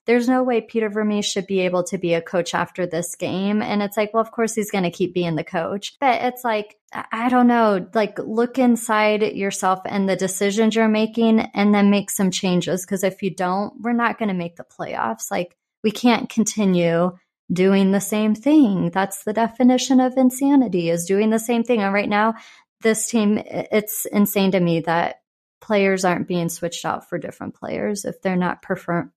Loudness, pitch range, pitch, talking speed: -20 LUFS, 185-225 Hz, 205 Hz, 205 wpm